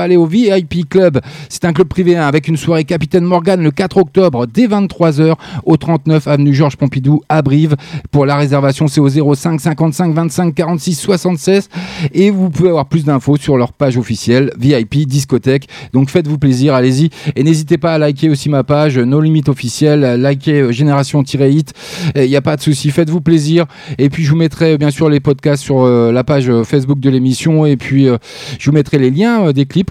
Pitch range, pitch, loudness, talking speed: 140-165 Hz, 150 Hz, -12 LUFS, 200 wpm